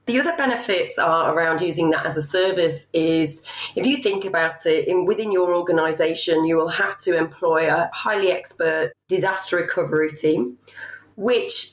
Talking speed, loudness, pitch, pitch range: 165 wpm, -21 LUFS, 170 Hz, 160-200 Hz